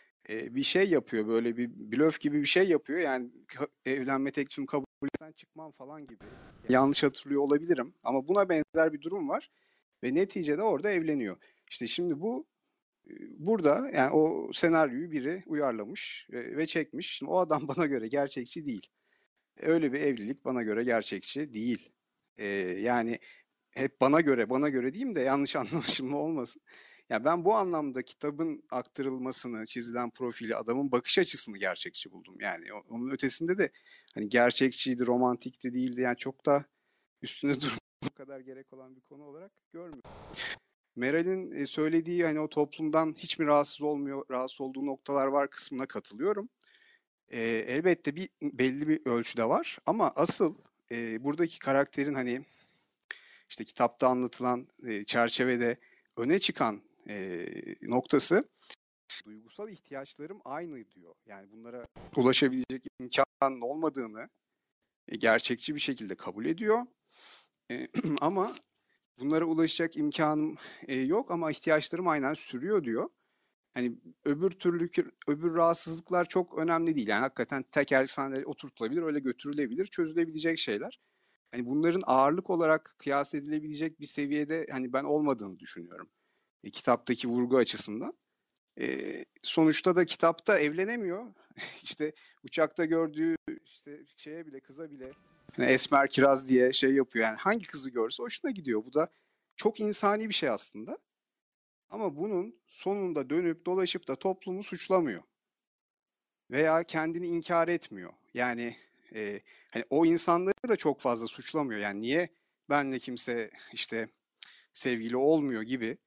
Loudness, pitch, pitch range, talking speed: -30 LUFS, 145 Hz, 130-170 Hz, 130 wpm